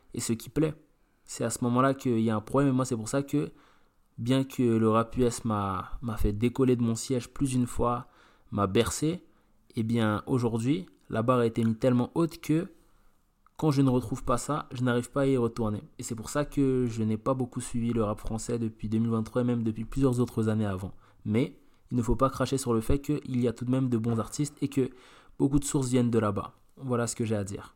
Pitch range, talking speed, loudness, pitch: 115-135 Hz, 245 wpm, -29 LUFS, 120 Hz